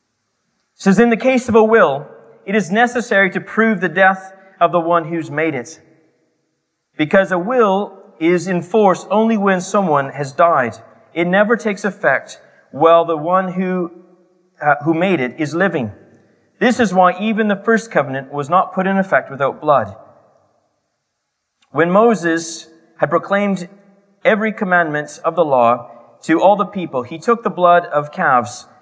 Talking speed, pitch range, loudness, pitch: 160 wpm, 165-205 Hz, -16 LUFS, 185 Hz